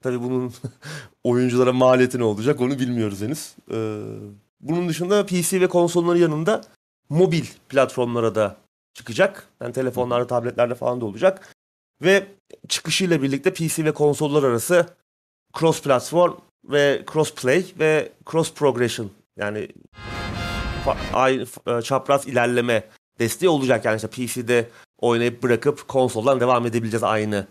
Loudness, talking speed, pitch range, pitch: -21 LUFS, 120 wpm, 120-160 Hz, 130 Hz